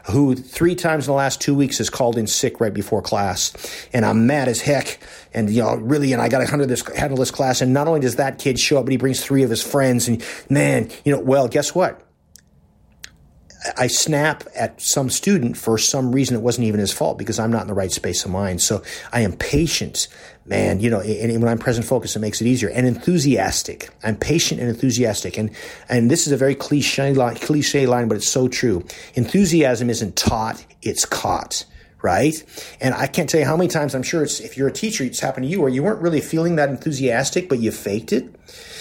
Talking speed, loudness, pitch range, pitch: 230 wpm, -19 LUFS, 115-145 Hz, 130 Hz